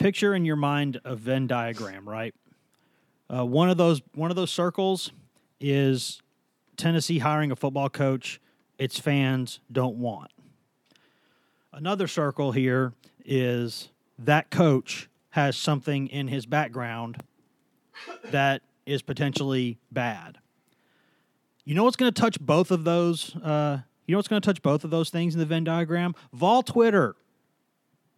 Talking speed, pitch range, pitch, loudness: 145 wpm, 130-170 Hz, 145 Hz, -26 LUFS